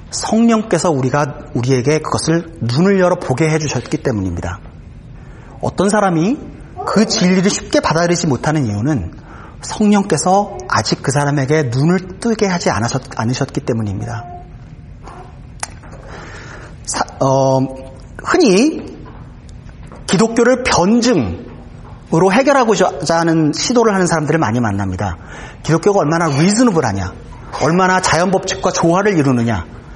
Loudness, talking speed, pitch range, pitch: -15 LUFS, 280 characters per minute, 130-190 Hz, 160 Hz